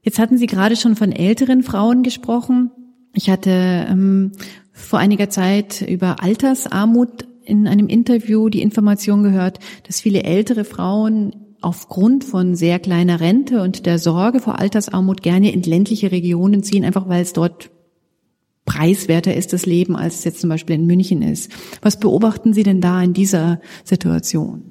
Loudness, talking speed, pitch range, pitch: -16 LUFS, 160 wpm, 180-220 Hz, 195 Hz